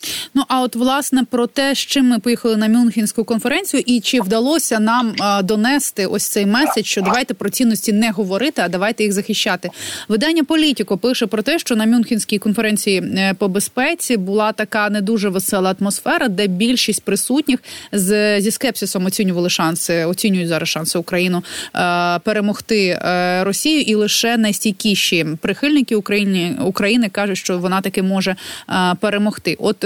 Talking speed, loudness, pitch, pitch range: 160 wpm, -17 LUFS, 215 Hz, 195-240 Hz